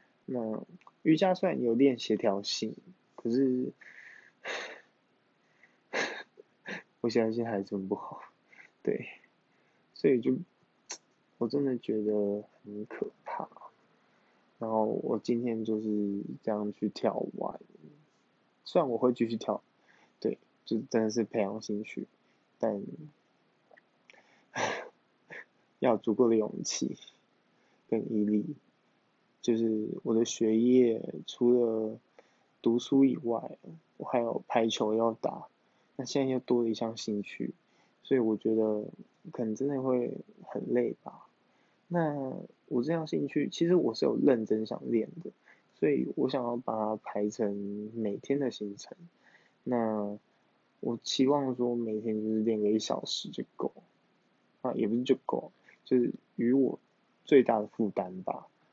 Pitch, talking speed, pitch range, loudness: 115 Hz, 180 characters per minute, 110-125 Hz, -31 LUFS